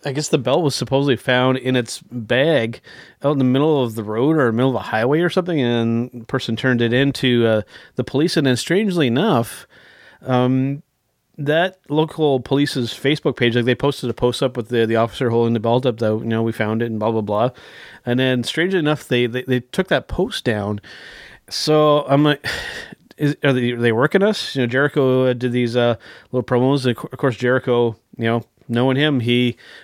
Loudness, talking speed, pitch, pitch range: -19 LUFS, 210 wpm, 125 Hz, 120-145 Hz